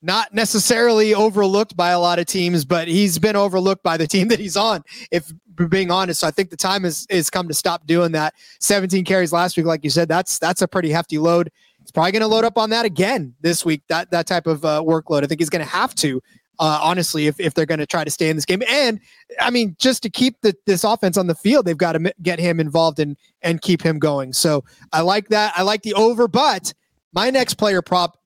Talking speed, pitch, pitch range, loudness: 255 wpm, 180 Hz, 165-210 Hz, -18 LUFS